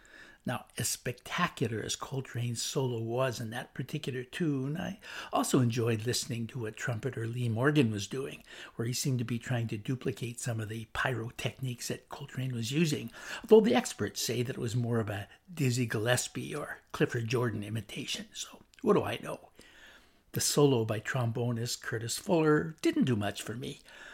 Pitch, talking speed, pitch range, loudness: 125 Hz, 175 wpm, 115-140 Hz, -32 LUFS